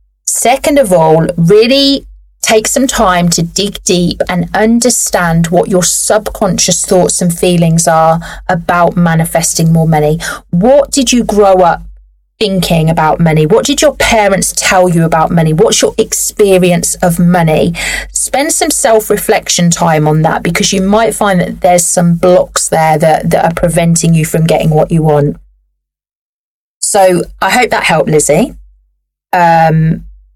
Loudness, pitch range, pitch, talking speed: -9 LUFS, 160-205 Hz, 175 Hz, 150 wpm